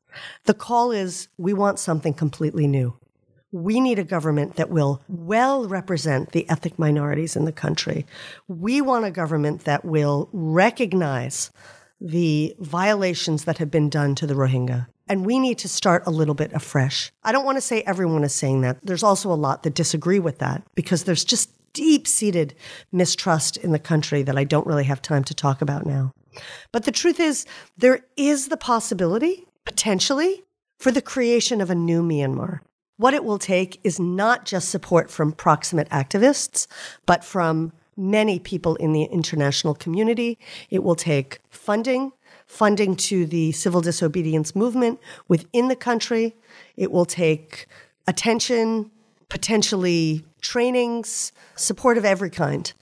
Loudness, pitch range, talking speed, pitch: -22 LUFS, 155-225 Hz, 160 wpm, 180 Hz